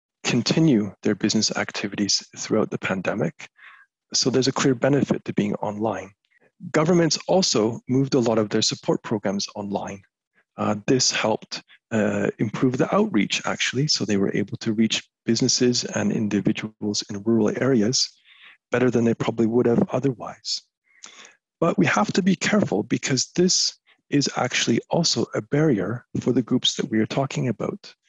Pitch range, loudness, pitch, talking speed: 105-140 Hz, -22 LUFS, 120 Hz, 155 wpm